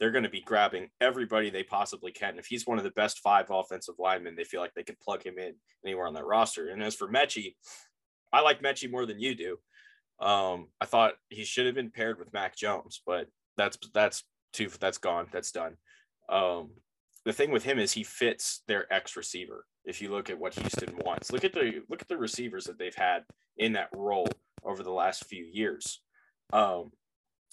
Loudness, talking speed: -31 LUFS, 215 wpm